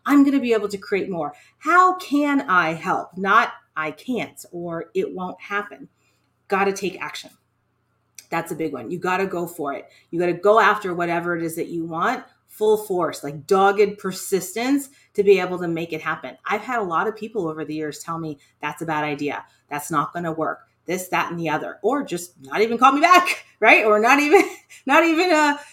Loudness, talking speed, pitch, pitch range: -21 LUFS, 220 wpm, 180 Hz, 160-240 Hz